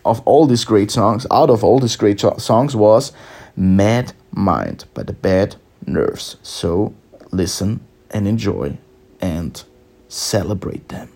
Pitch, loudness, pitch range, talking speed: 105 Hz, -17 LUFS, 95-115 Hz, 135 wpm